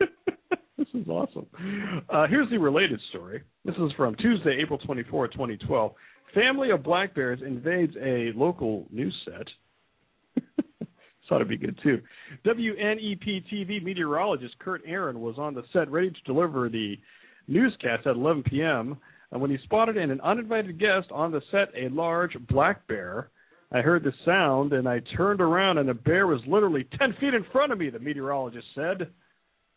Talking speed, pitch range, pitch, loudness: 165 wpm, 140-210 Hz, 170 Hz, -27 LUFS